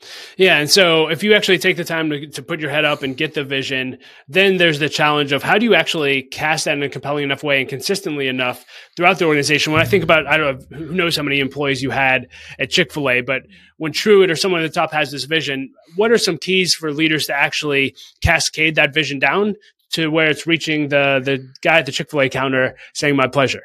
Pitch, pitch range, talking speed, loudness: 150 Hz, 140-170 Hz, 250 wpm, -16 LUFS